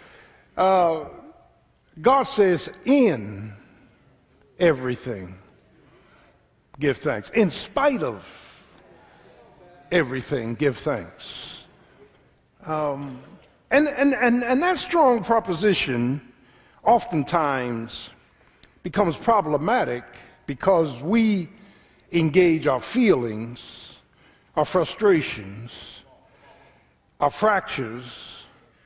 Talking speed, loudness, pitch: 70 wpm, -22 LUFS, 155 Hz